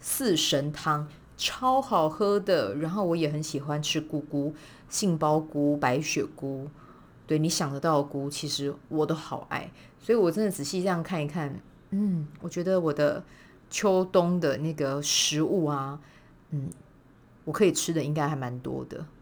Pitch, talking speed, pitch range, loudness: 155 Hz, 230 characters per minute, 145-170 Hz, -28 LUFS